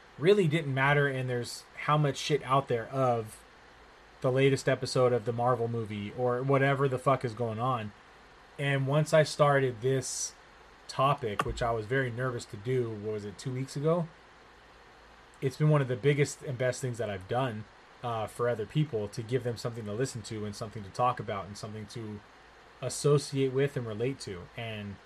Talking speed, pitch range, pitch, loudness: 195 wpm, 115-135 Hz, 125 Hz, -30 LUFS